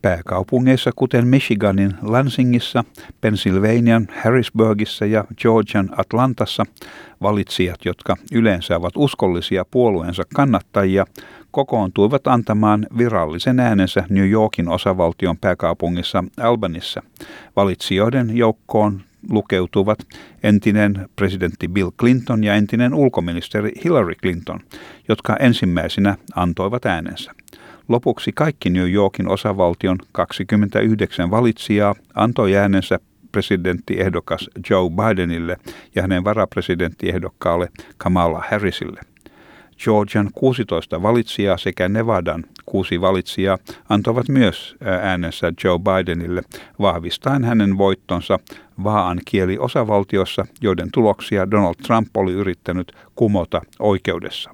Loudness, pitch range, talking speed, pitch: -18 LUFS, 90-110 Hz, 90 wpm, 100 Hz